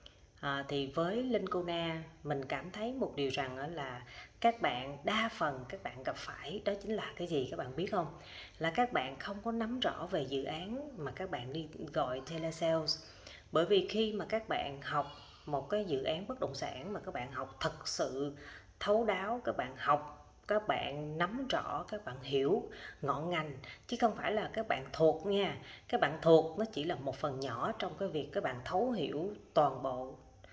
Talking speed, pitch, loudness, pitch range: 210 wpm, 160 Hz, -36 LUFS, 140-210 Hz